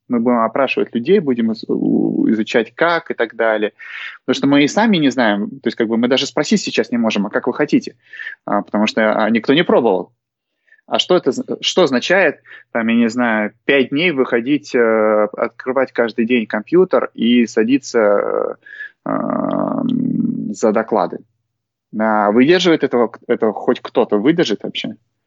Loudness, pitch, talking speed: -16 LUFS, 120 Hz, 150 wpm